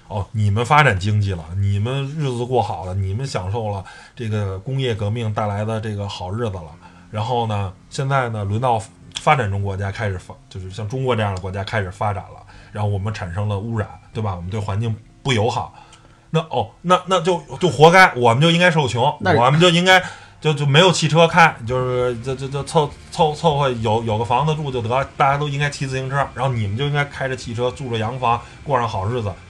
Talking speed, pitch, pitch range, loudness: 325 characters per minute, 120 Hz, 105-140 Hz, -19 LUFS